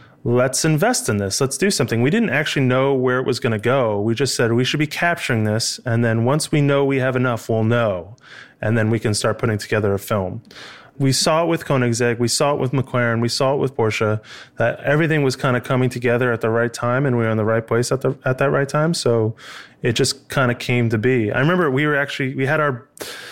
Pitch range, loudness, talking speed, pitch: 115-140 Hz, -19 LUFS, 255 wpm, 125 Hz